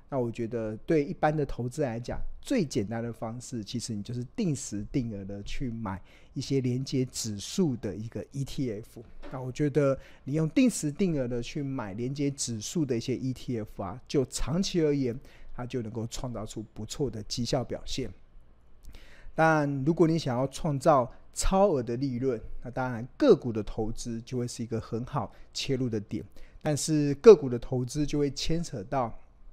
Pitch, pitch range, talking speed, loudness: 125 Hz, 115-145 Hz, 260 characters per minute, -29 LUFS